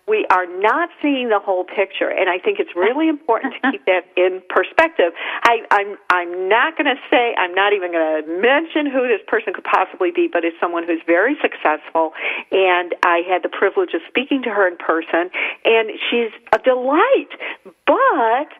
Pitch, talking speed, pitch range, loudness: 215 Hz, 185 wpm, 180-280 Hz, -17 LUFS